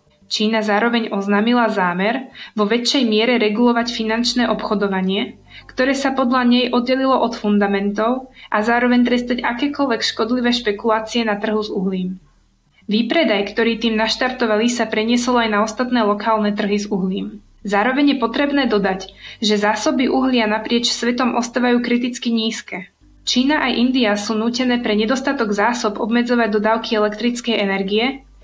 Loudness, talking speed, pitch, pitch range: -18 LUFS, 135 wpm, 230 Hz, 215-245 Hz